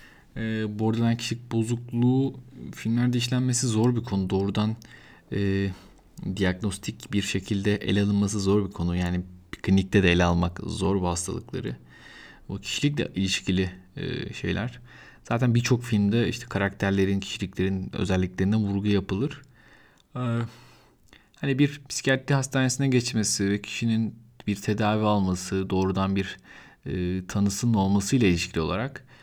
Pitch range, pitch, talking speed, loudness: 95-120 Hz, 105 Hz, 125 wpm, -26 LUFS